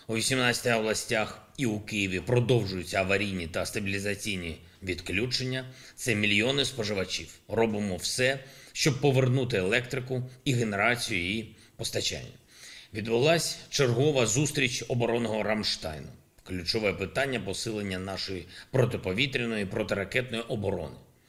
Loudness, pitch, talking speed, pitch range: -28 LUFS, 110 Hz, 100 wpm, 100-130 Hz